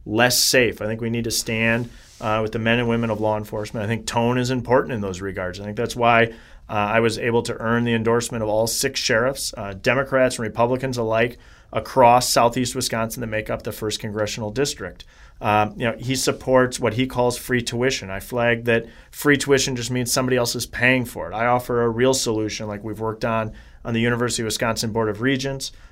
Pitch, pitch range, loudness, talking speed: 115 Hz, 110-125 Hz, -21 LUFS, 220 wpm